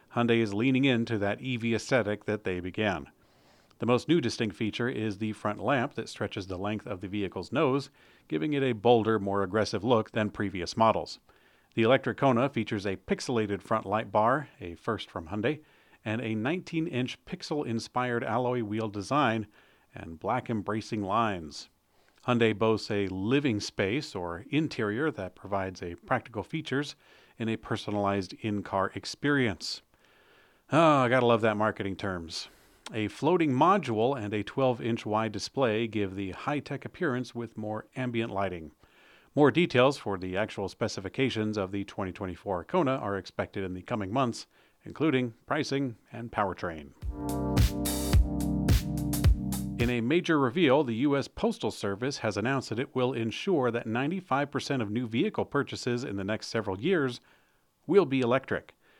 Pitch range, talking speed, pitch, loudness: 100-130 Hz, 150 wpm, 110 Hz, -29 LUFS